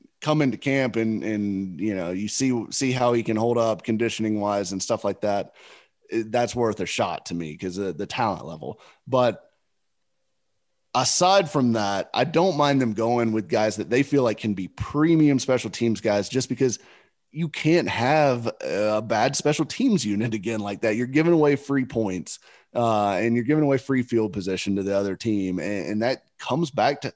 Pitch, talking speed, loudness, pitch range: 115 Hz, 195 wpm, -24 LUFS, 105-135 Hz